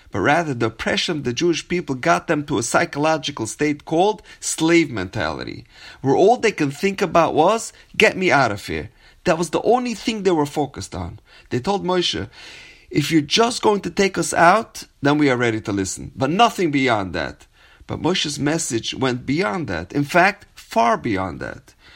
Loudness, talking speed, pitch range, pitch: -19 LUFS, 190 wpm, 135-190 Hz, 160 Hz